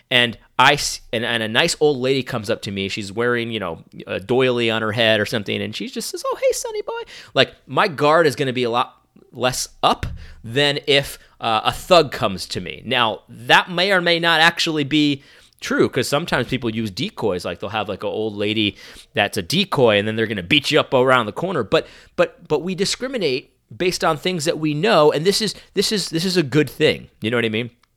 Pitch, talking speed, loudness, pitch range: 145 Hz, 240 wpm, -19 LUFS, 115-175 Hz